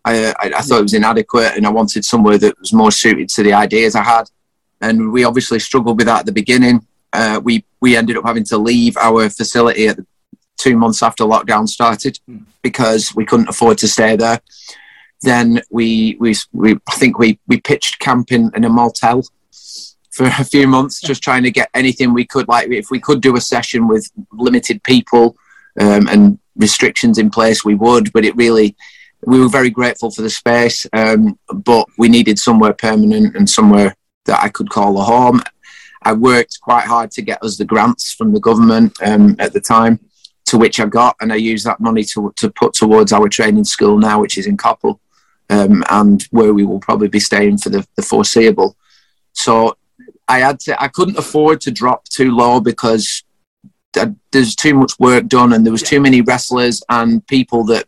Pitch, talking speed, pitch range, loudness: 120 Hz, 200 wpm, 110-130 Hz, -12 LUFS